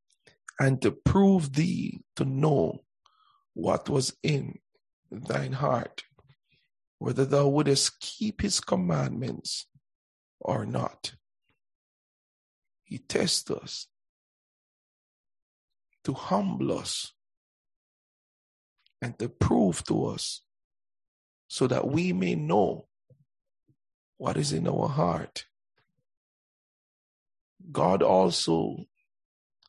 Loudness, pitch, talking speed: -27 LUFS, 140 Hz, 85 wpm